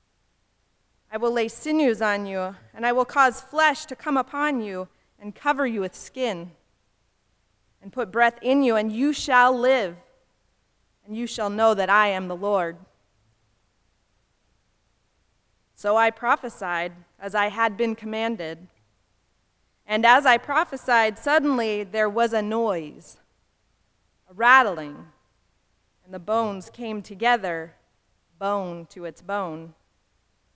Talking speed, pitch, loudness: 130 wpm, 200 Hz, -23 LUFS